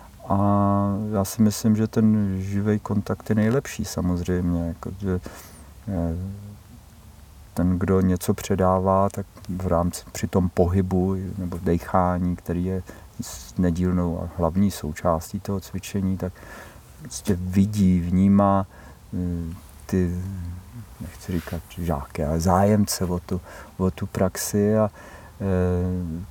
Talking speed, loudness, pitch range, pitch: 110 wpm, -24 LUFS, 90-100 Hz, 95 Hz